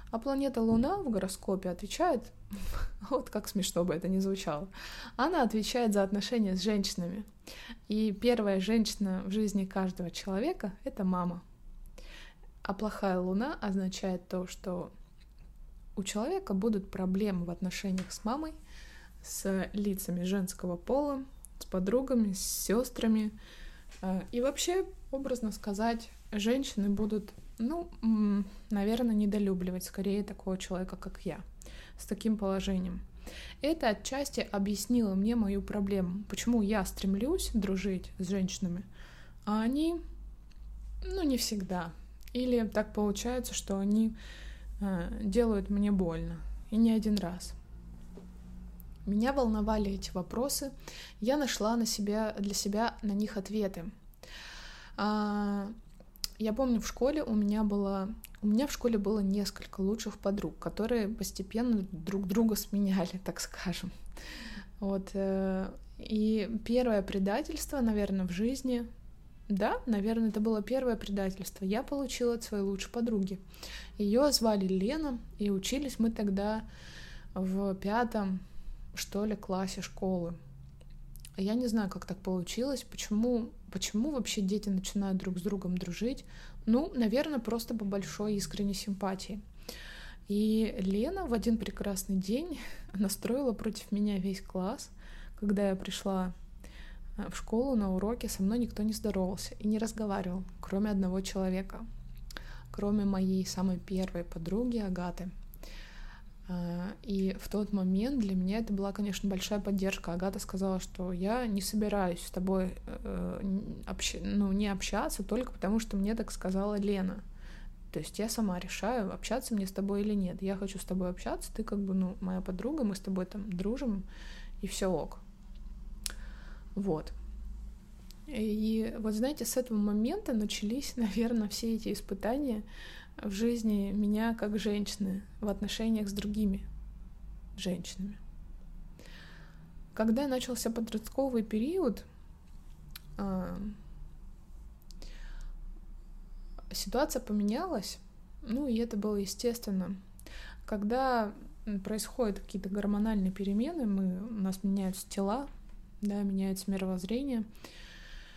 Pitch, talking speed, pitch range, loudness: 205 Hz, 125 wpm, 190-225 Hz, -33 LUFS